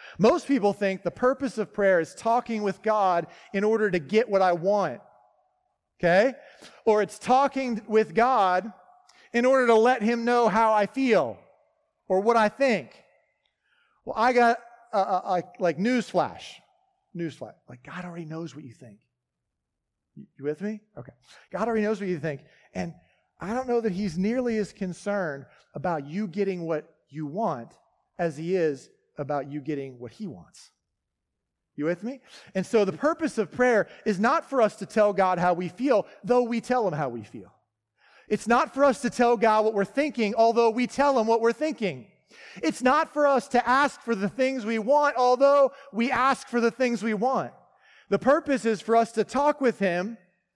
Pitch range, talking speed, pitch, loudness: 180-245 Hz, 190 wpm, 215 Hz, -25 LUFS